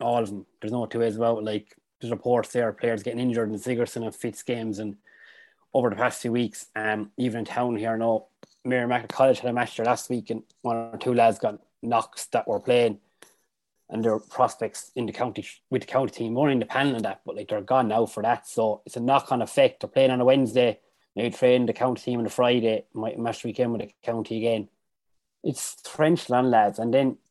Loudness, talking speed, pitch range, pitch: -25 LUFS, 230 wpm, 110-125 Hz, 115 Hz